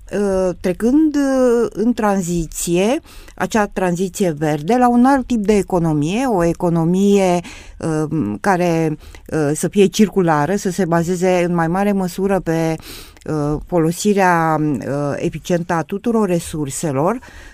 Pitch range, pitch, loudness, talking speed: 165-200 Hz, 180 Hz, -17 LUFS, 105 wpm